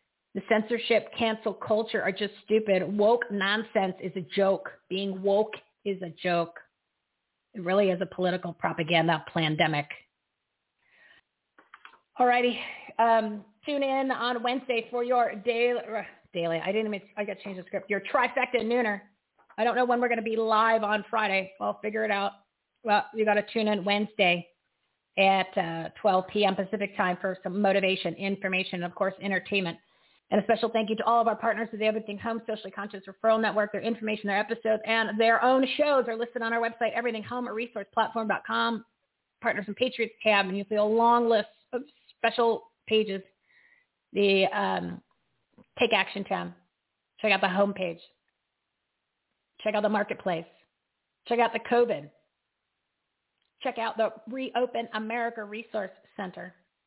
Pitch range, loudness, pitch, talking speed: 195-230 Hz, -27 LUFS, 215 Hz, 165 wpm